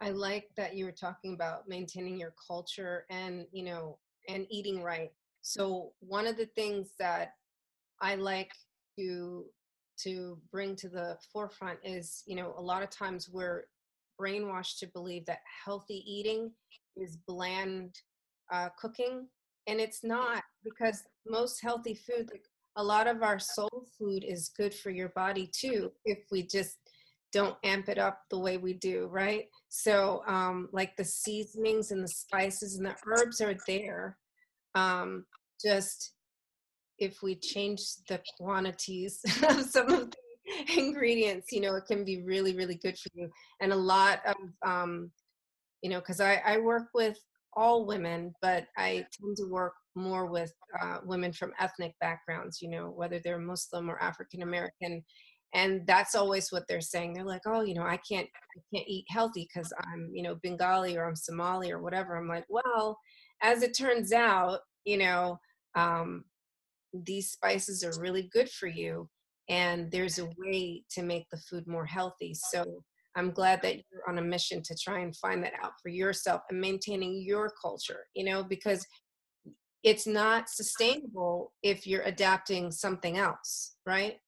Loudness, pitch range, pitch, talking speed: -33 LUFS, 180-210 Hz, 190 Hz, 165 wpm